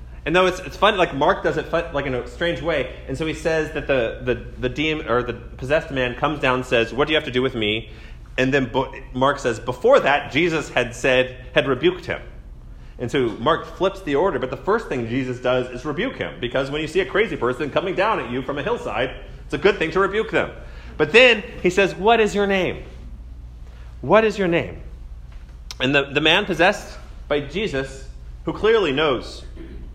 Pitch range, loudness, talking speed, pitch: 115-165 Hz, -20 LUFS, 220 wpm, 135 Hz